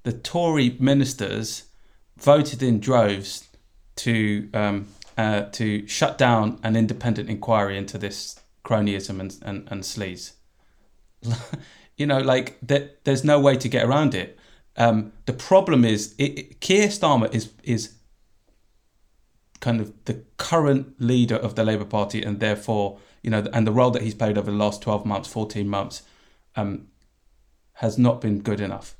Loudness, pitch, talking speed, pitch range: -23 LUFS, 110 Hz, 155 wpm, 105-125 Hz